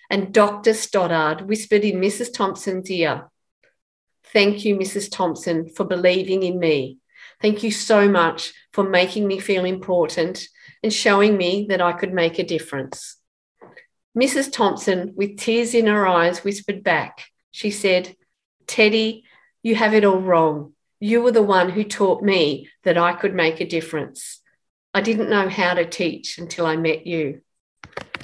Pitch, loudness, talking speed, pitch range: 195 Hz, -20 LUFS, 155 wpm, 175-210 Hz